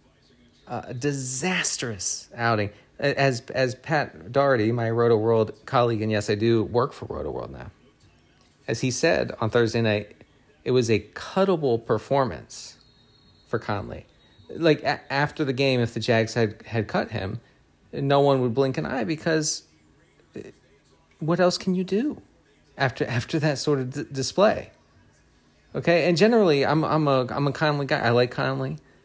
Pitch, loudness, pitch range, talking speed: 130 Hz, -24 LUFS, 115-145 Hz, 160 wpm